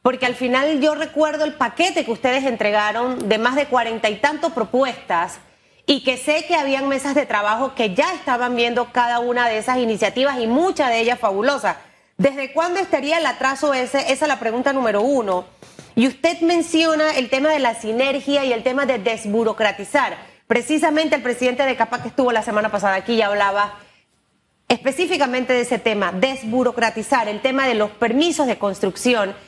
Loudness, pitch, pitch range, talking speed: -19 LUFS, 255 Hz, 230-285 Hz, 180 wpm